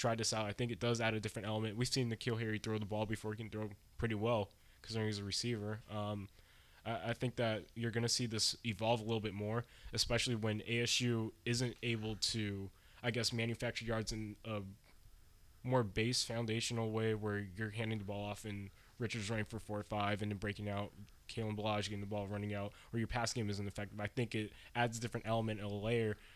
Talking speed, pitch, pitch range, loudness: 225 wpm, 110 Hz, 105-115 Hz, -39 LUFS